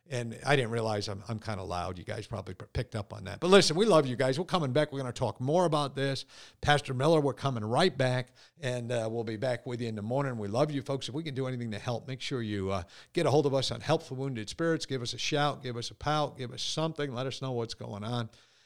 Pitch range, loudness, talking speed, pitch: 115-145 Hz, -31 LUFS, 285 wpm, 125 Hz